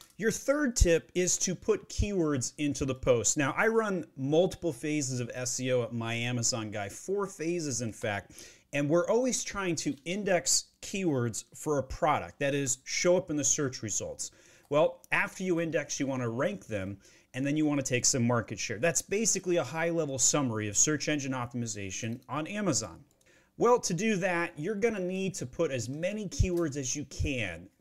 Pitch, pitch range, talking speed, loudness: 150 Hz, 125-175 Hz, 190 wpm, -30 LUFS